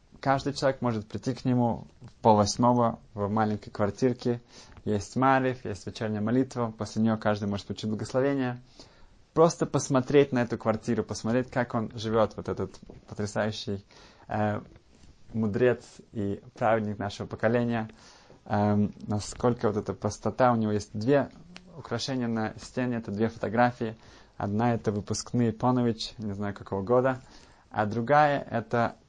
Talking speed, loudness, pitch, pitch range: 135 wpm, -28 LUFS, 115 Hz, 105-125 Hz